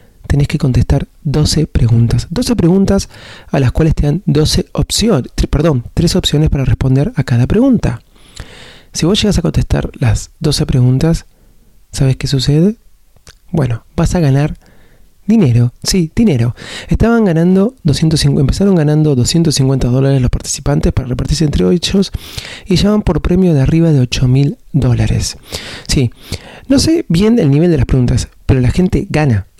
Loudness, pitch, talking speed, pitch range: -13 LUFS, 145 Hz, 155 wpm, 125-170 Hz